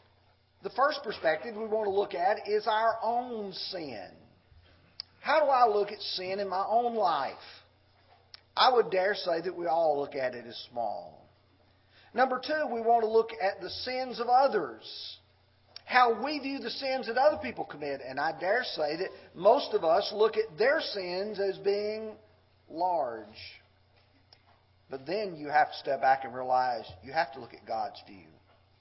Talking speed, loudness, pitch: 175 wpm, -29 LUFS, 185 Hz